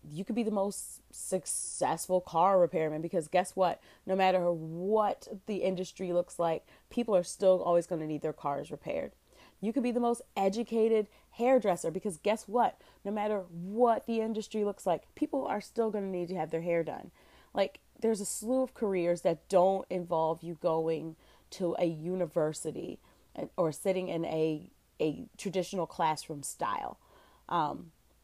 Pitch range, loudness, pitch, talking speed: 170-215 Hz, -32 LUFS, 185 Hz, 170 wpm